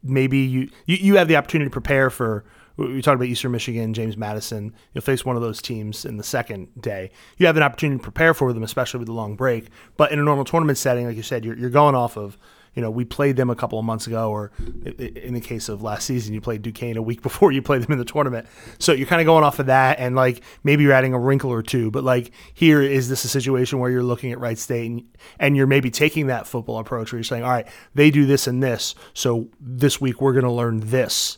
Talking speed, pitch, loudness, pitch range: 265 wpm, 125 Hz, -20 LUFS, 115-135 Hz